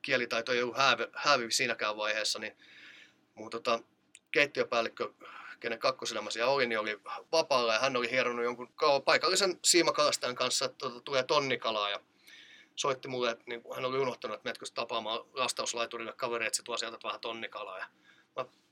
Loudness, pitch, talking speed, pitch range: -31 LUFS, 120 Hz, 145 wpm, 115-135 Hz